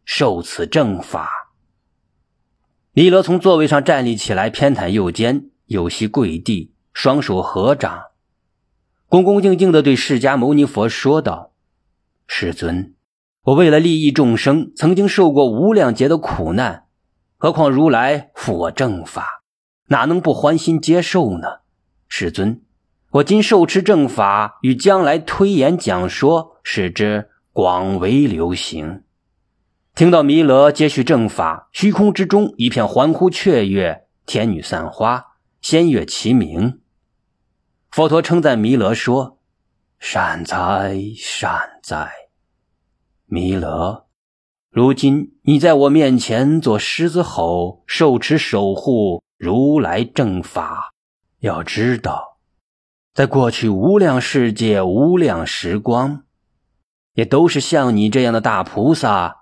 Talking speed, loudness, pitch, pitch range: 180 characters per minute, -16 LUFS, 130 Hz, 100-160 Hz